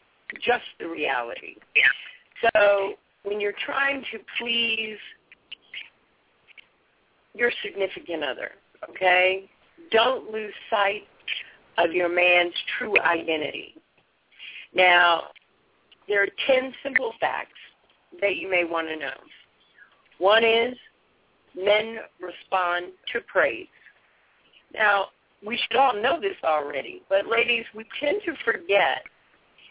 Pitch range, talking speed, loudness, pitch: 185-250 Hz, 105 wpm, -23 LUFS, 215 Hz